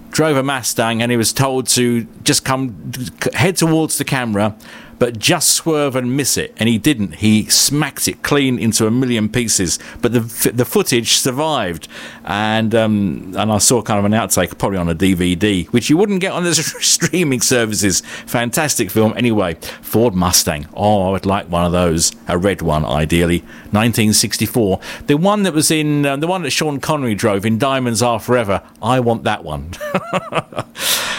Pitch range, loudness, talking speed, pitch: 100-135 Hz, -15 LUFS, 185 wpm, 115 Hz